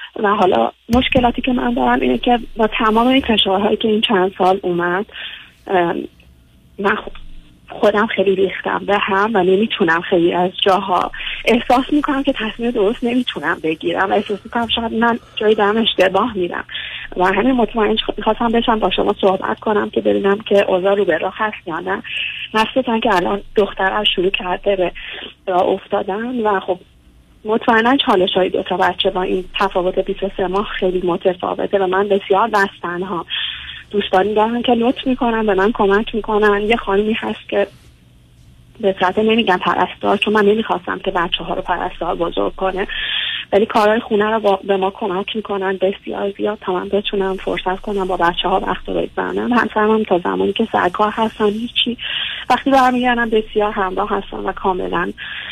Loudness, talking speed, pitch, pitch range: -17 LUFS, 170 wpm, 200 Hz, 185-220 Hz